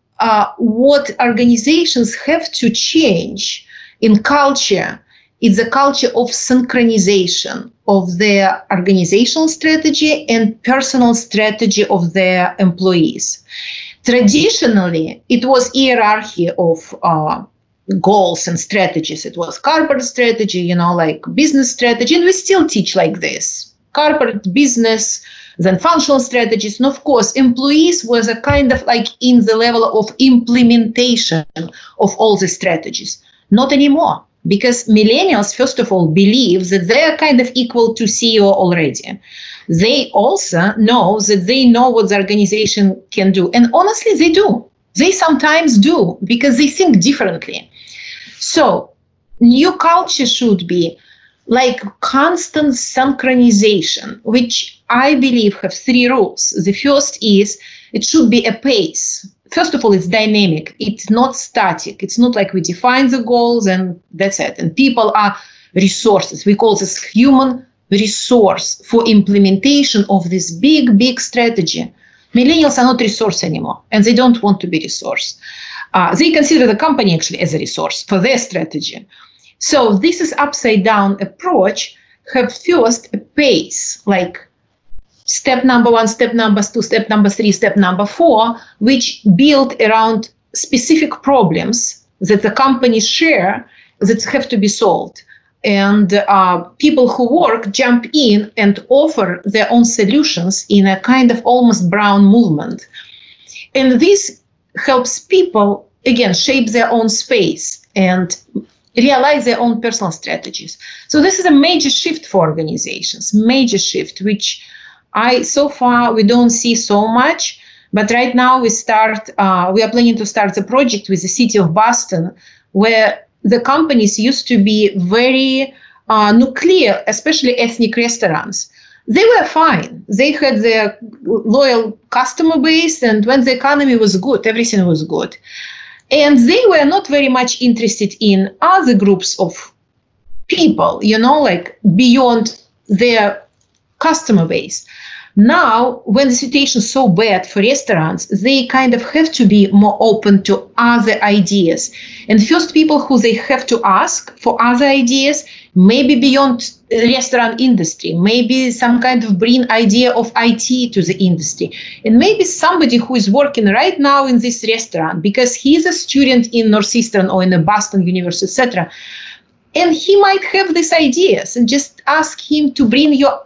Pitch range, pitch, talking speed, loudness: 205-265 Hz, 235 Hz, 150 wpm, -12 LUFS